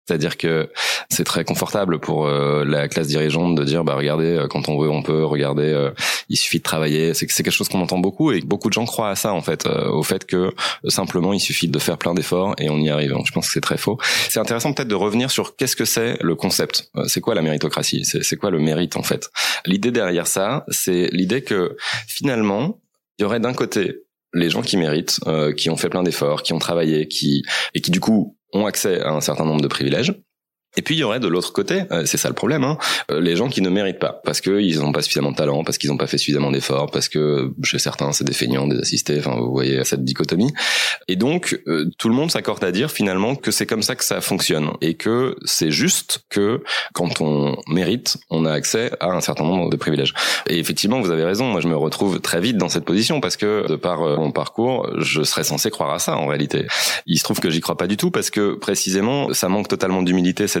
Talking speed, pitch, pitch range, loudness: 245 wpm, 75 Hz, 70-85 Hz, -19 LUFS